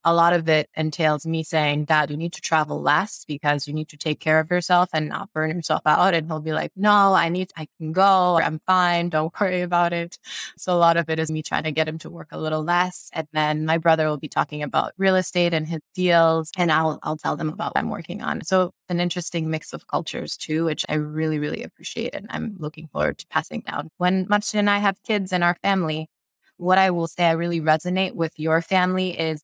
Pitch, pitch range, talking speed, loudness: 165 Hz, 155-180 Hz, 245 wpm, -22 LUFS